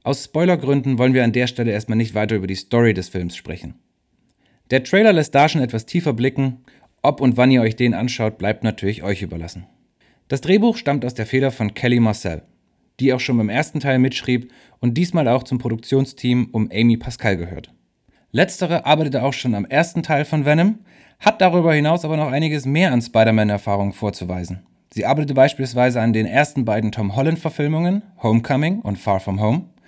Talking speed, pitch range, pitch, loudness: 185 wpm, 110-145 Hz, 125 Hz, -19 LUFS